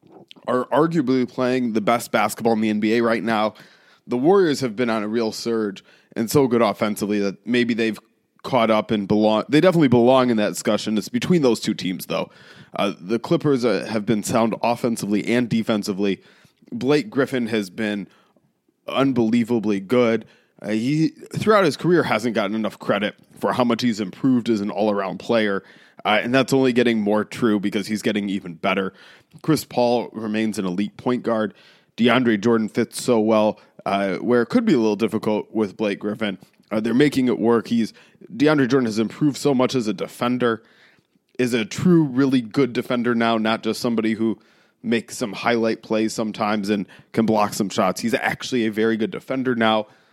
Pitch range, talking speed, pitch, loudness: 105-125 Hz, 185 wpm, 115 Hz, -21 LUFS